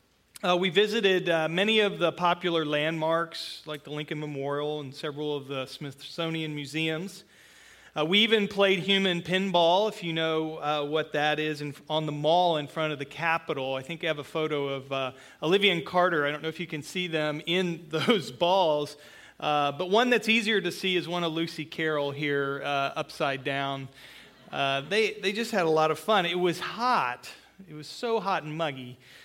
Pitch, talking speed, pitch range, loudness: 160 Hz, 200 wpm, 150-180 Hz, -27 LUFS